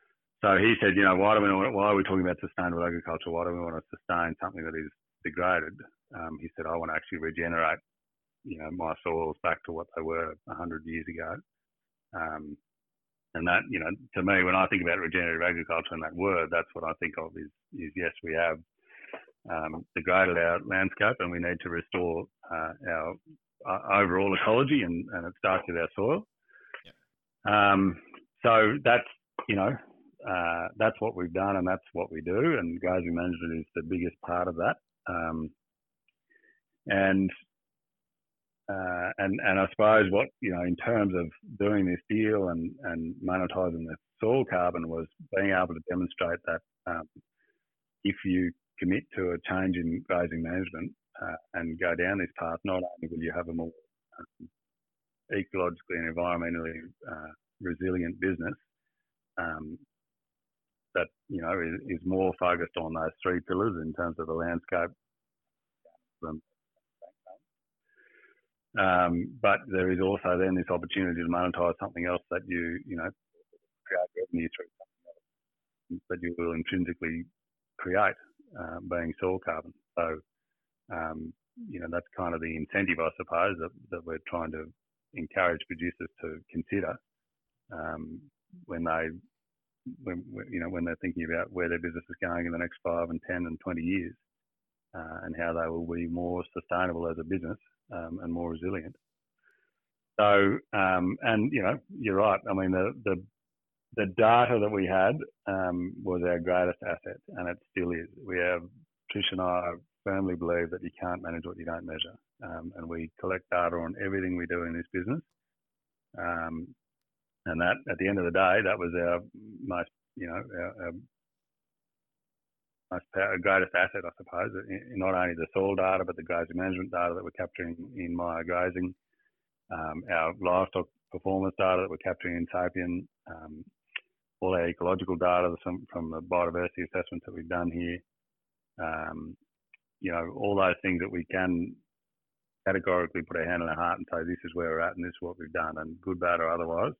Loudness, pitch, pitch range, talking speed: -30 LUFS, 90 Hz, 85-95 Hz, 175 wpm